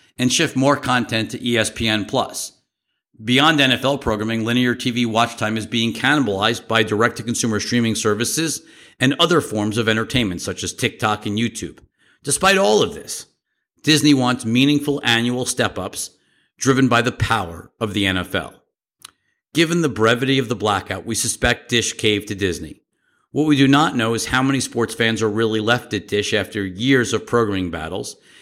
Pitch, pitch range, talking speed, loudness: 115 Hz, 110-130 Hz, 165 wpm, -19 LUFS